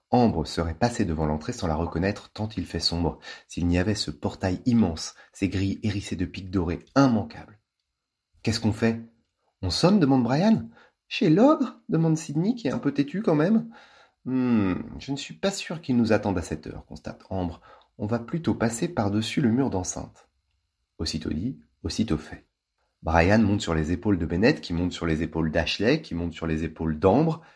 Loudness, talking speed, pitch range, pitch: -25 LUFS, 190 wpm, 85-125 Hz, 100 Hz